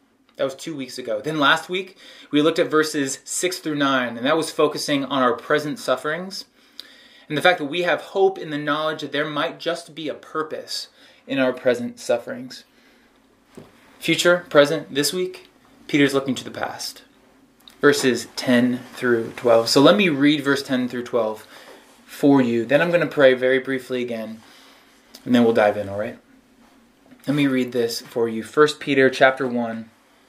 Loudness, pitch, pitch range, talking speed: -21 LUFS, 145 Hz, 125-160 Hz, 180 wpm